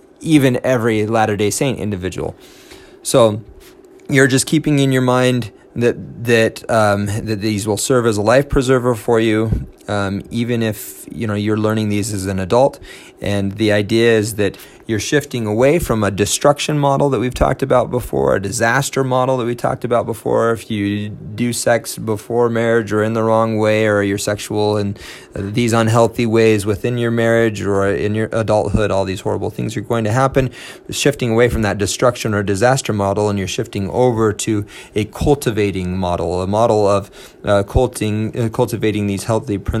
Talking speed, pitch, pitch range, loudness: 180 wpm, 110 Hz, 105-120 Hz, -17 LUFS